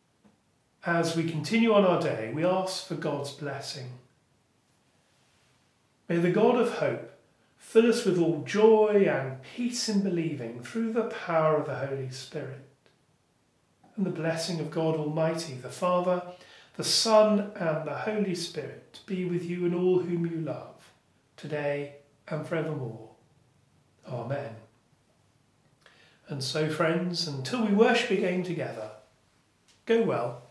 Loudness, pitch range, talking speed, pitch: -28 LUFS, 140-185 Hz, 135 wpm, 160 Hz